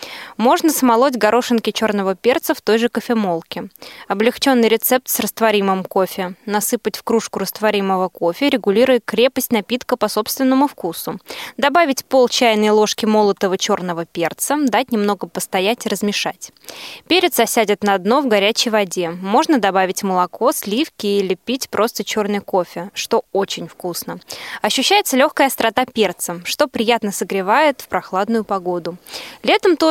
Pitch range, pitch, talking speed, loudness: 195-250 Hz, 215 Hz, 135 wpm, -17 LUFS